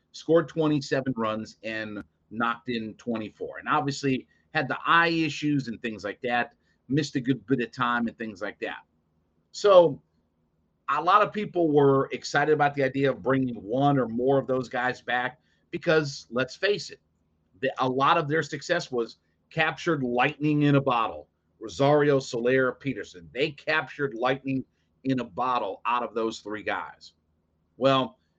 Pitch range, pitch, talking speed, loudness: 110-145 Hz, 130 Hz, 165 wpm, -26 LUFS